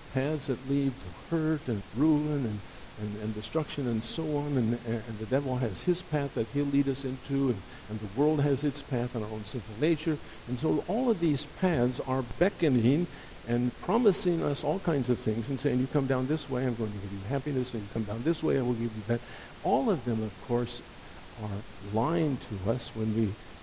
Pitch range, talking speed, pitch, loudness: 110-145 Hz, 225 wpm, 130 Hz, -30 LUFS